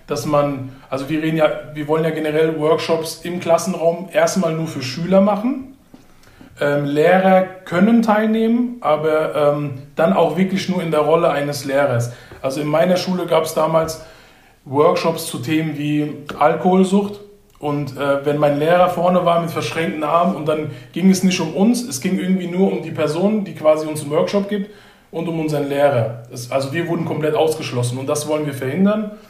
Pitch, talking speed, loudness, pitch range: 160 Hz, 185 wpm, -18 LUFS, 150-180 Hz